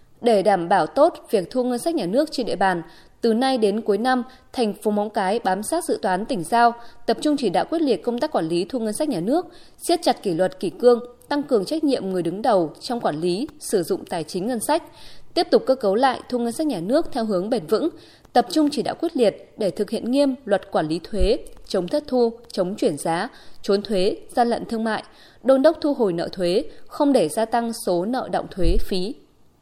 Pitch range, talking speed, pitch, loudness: 200-290 Hz, 245 wpm, 240 Hz, -22 LUFS